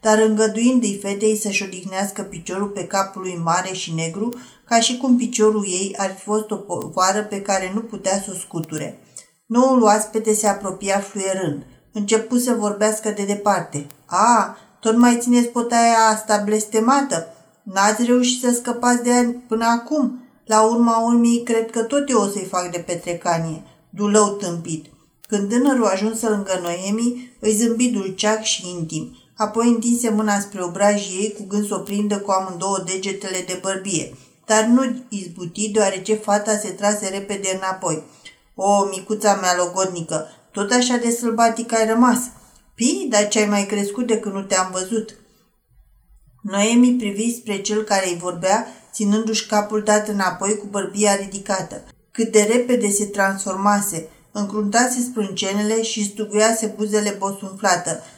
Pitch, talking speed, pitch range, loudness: 205 Hz, 155 wpm, 190-225 Hz, -20 LUFS